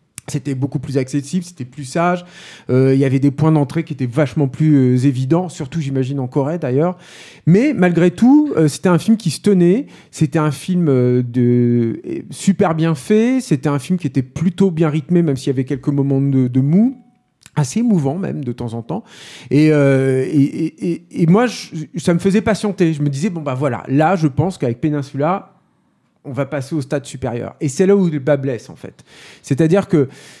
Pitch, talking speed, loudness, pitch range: 155 Hz, 210 wpm, -16 LUFS, 140-180 Hz